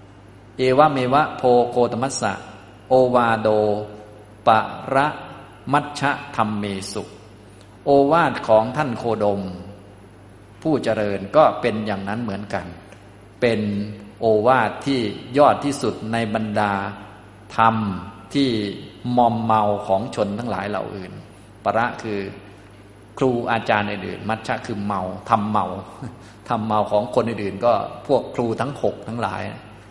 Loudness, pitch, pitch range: -21 LUFS, 105 Hz, 100-120 Hz